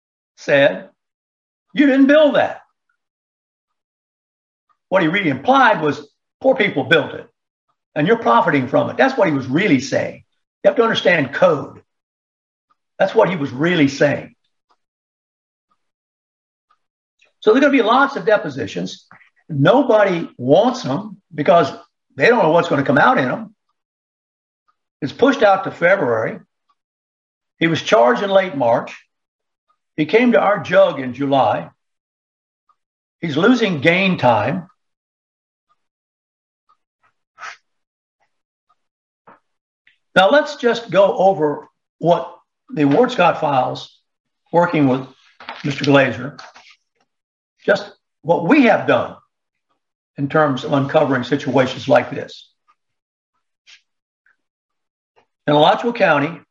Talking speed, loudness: 115 wpm, -16 LUFS